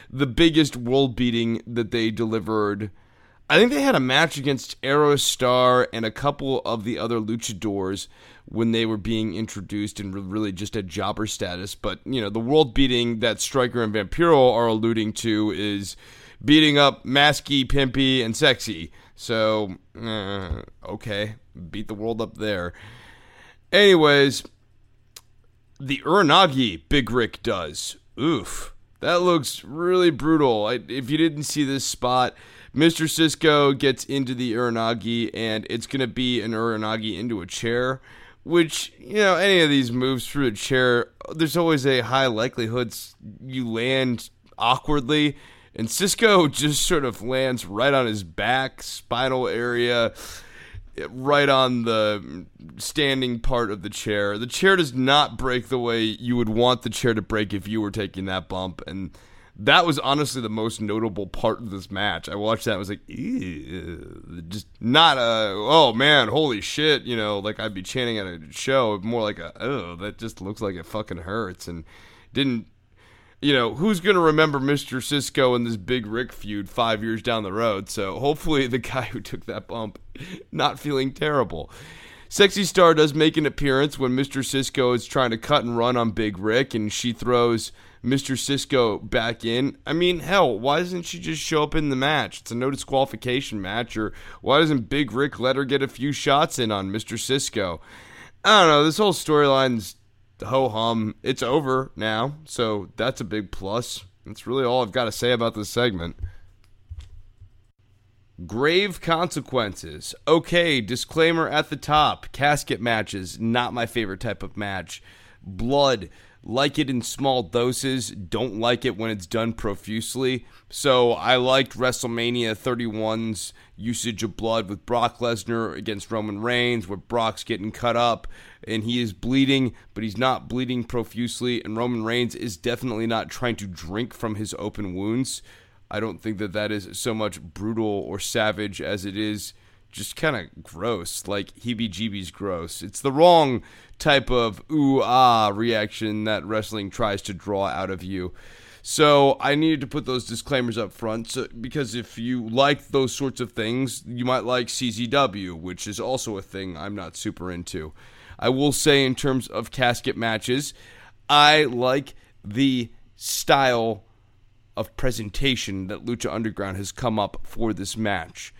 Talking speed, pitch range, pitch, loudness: 170 wpm, 105-130 Hz, 115 Hz, -22 LUFS